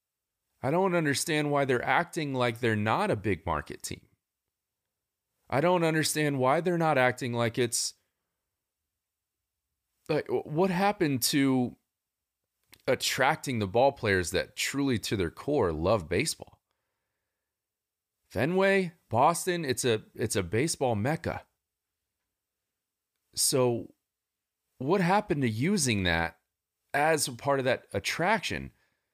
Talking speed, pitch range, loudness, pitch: 115 wpm, 100-150 Hz, -28 LUFS, 125 Hz